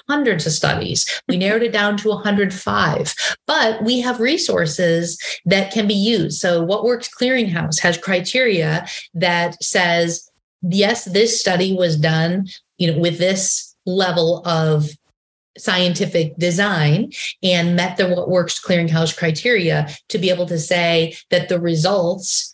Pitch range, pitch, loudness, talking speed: 170-205 Hz, 180 Hz, -18 LUFS, 140 wpm